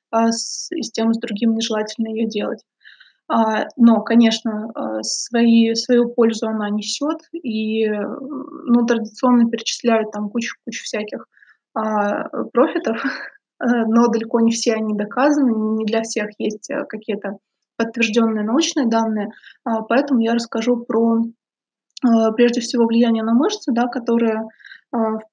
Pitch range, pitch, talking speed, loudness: 220-245 Hz, 230 Hz, 120 wpm, -19 LUFS